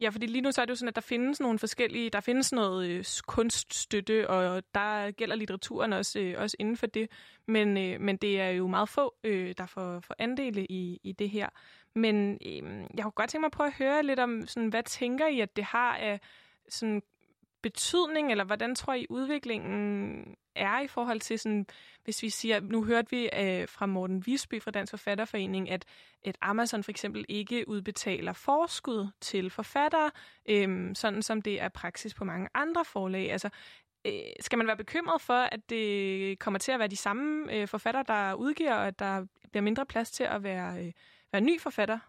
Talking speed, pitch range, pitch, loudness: 205 wpm, 200-245 Hz, 215 Hz, -31 LUFS